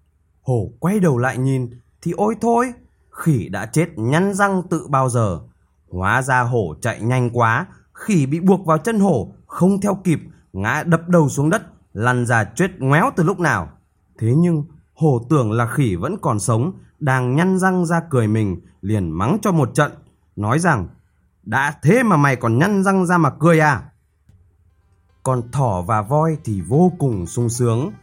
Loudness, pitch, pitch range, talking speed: -18 LUFS, 140 Hz, 115-170 Hz, 180 wpm